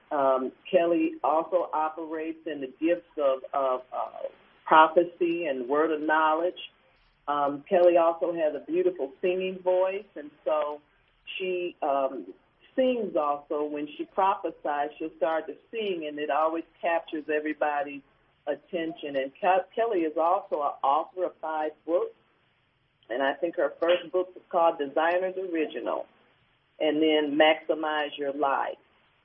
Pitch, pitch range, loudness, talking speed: 160 Hz, 150-180 Hz, -27 LUFS, 135 wpm